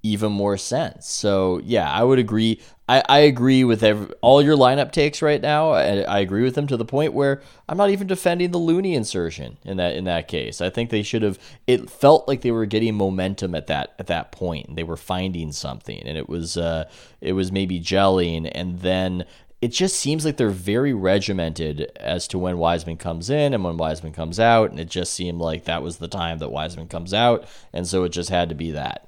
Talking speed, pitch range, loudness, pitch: 225 wpm, 85-125 Hz, -21 LUFS, 100 Hz